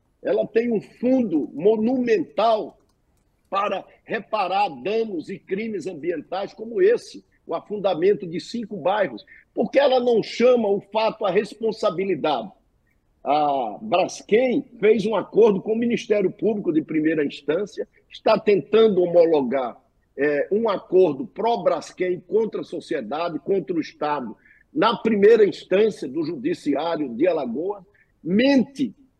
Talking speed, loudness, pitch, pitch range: 120 wpm, -22 LUFS, 225 Hz, 200-275 Hz